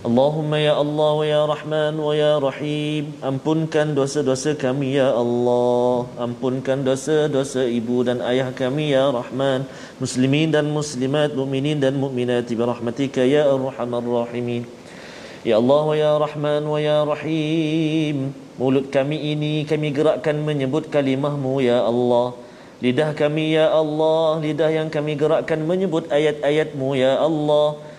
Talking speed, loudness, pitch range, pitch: 135 wpm, -20 LUFS, 130-150 Hz, 145 Hz